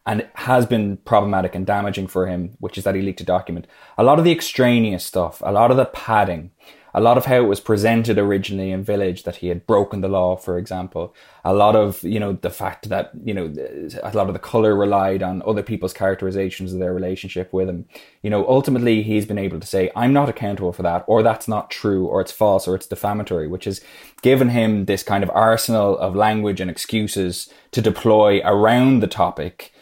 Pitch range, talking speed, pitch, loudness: 95-110 Hz, 220 wpm, 100 Hz, -19 LUFS